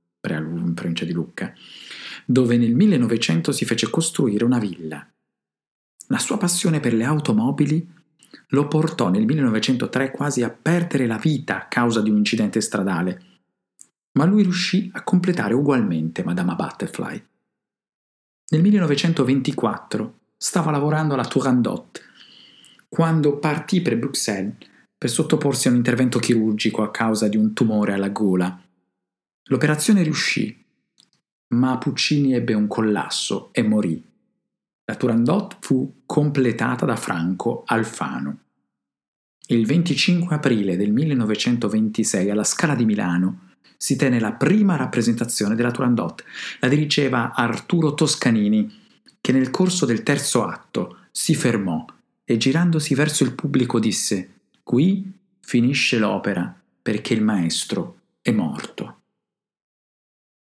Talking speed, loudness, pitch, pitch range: 120 wpm, -21 LUFS, 125 Hz, 110-155 Hz